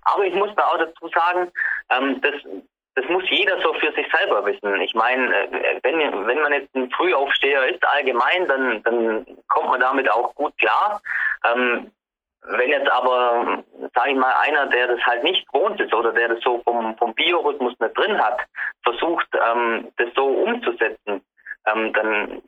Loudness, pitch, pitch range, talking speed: -20 LUFS, 125 Hz, 115-170 Hz, 165 wpm